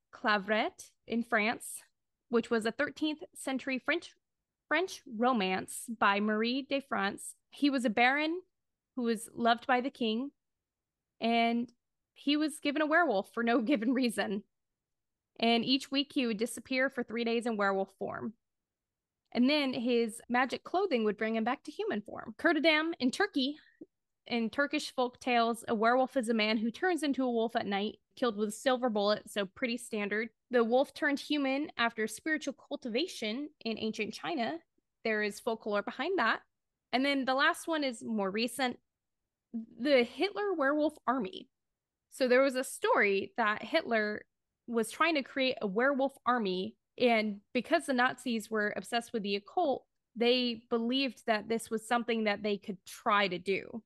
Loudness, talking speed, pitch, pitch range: -32 LUFS, 165 wpm, 245 Hz, 225-275 Hz